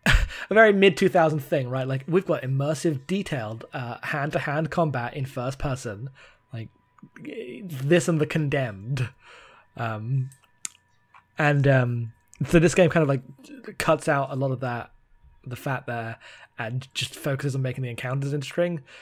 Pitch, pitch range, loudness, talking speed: 135 Hz, 125-160 Hz, -25 LUFS, 155 wpm